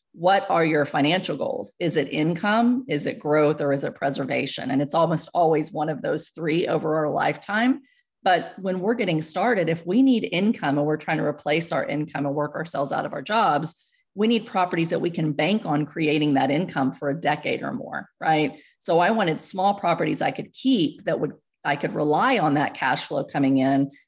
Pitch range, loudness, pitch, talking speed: 150-190 Hz, -23 LUFS, 160 Hz, 210 wpm